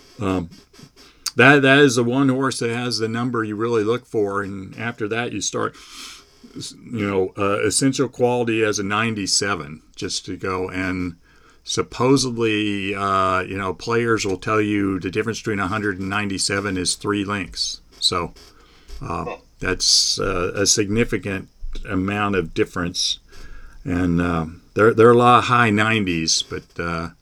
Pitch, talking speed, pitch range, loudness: 105 Hz, 150 wpm, 95-115 Hz, -20 LUFS